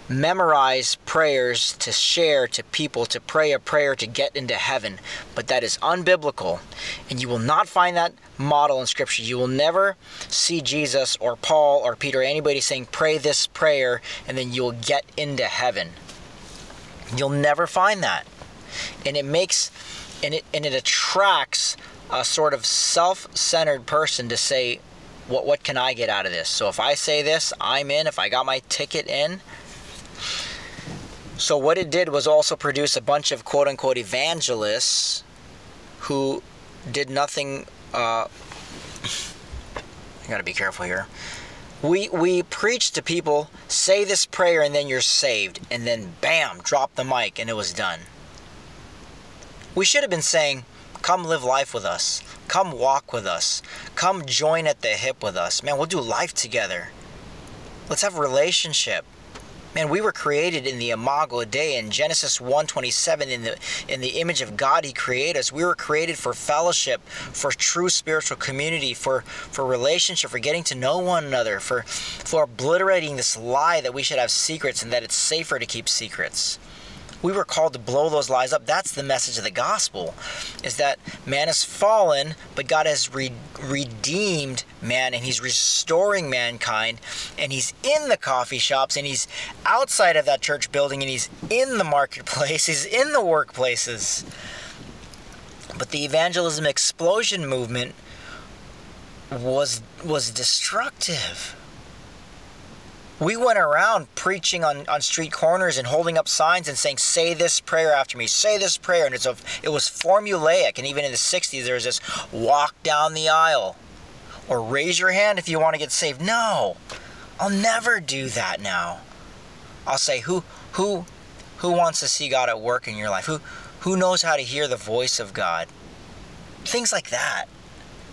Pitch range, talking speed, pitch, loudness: 130-170 Hz, 170 wpm, 150 Hz, -22 LUFS